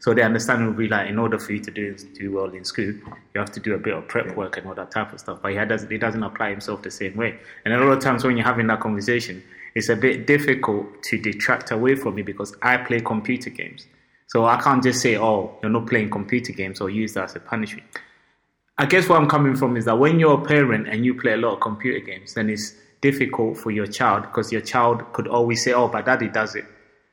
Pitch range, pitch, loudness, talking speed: 105-125 Hz, 115 Hz, -21 LUFS, 265 wpm